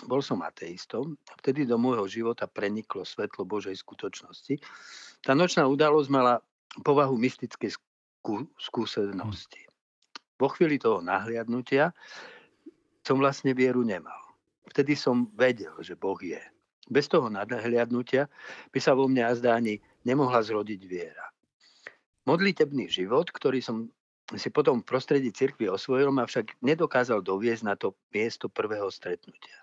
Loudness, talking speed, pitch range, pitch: -28 LUFS, 130 wpm, 115-140 Hz, 125 Hz